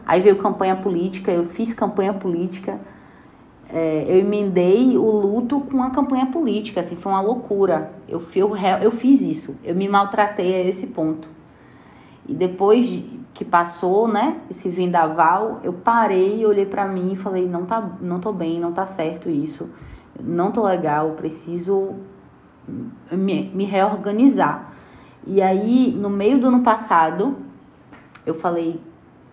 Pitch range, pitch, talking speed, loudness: 175-215 Hz, 195 Hz, 145 wpm, -20 LUFS